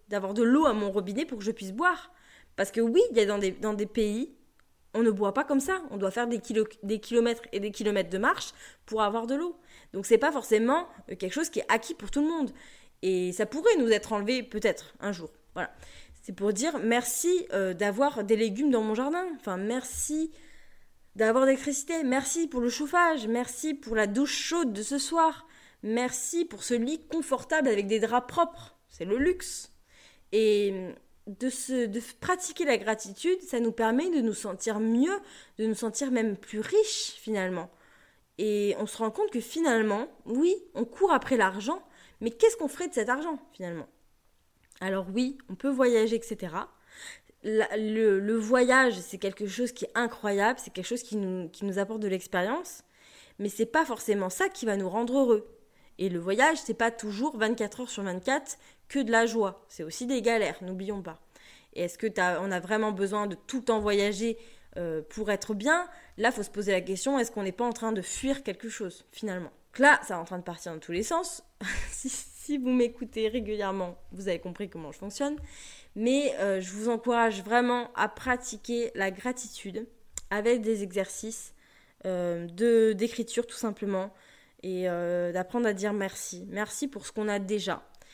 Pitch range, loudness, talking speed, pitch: 205-265 Hz, -29 LUFS, 195 wpm, 225 Hz